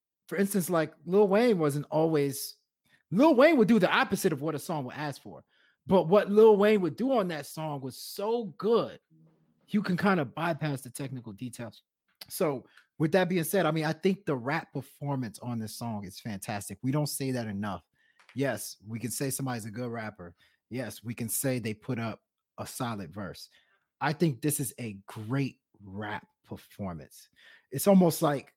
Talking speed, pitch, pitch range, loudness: 190 wpm, 145 Hz, 120-180 Hz, -29 LUFS